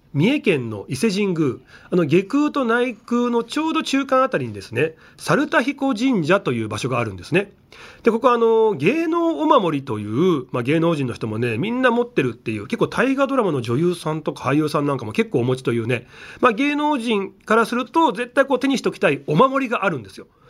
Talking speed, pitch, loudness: 420 characters per minute, 225 Hz, -20 LUFS